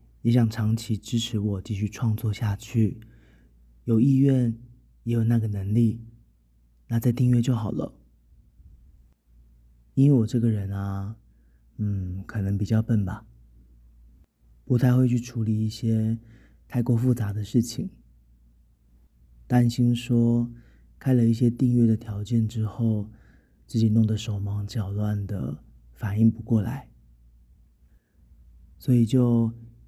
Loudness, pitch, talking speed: -25 LUFS, 105 Hz, 180 characters per minute